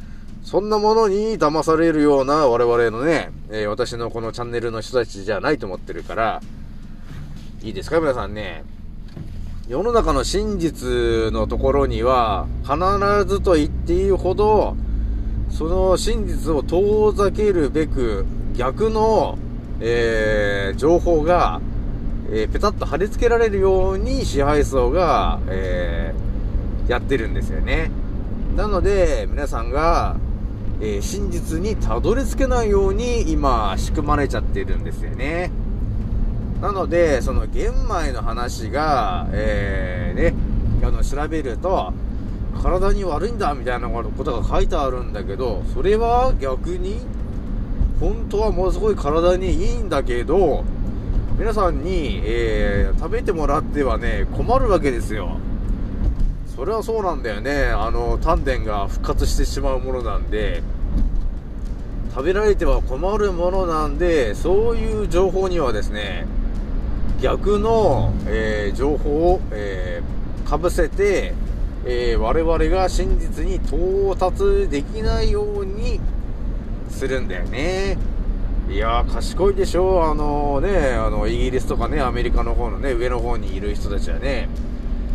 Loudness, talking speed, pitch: -21 LUFS, 260 characters per minute, 120 Hz